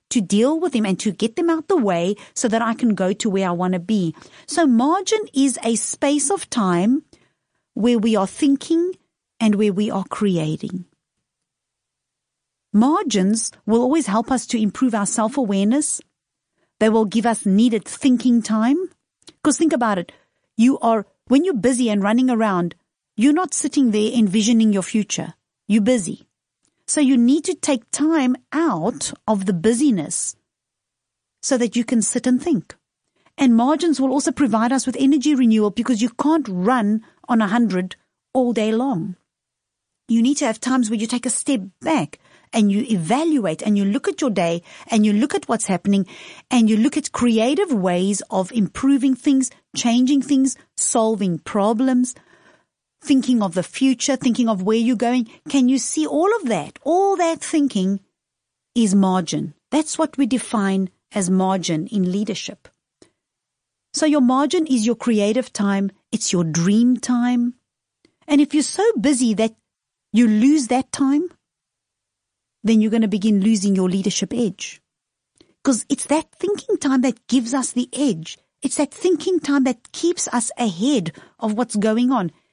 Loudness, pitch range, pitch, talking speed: -19 LUFS, 210-275 Hz, 240 Hz, 170 wpm